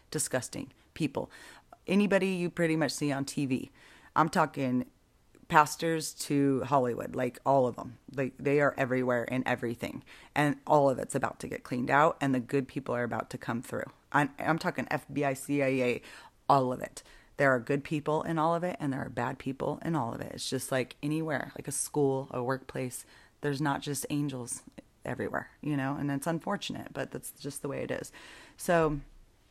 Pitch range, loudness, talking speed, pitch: 130-150 Hz, -31 LUFS, 190 wpm, 140 Hz